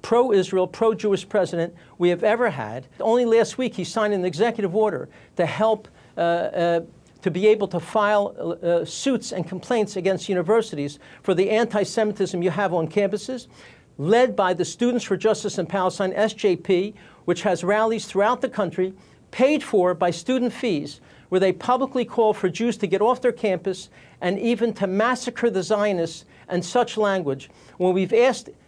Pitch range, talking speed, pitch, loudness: 180-225 Hz, 175 wpm, 200 Hz, -22 LUFS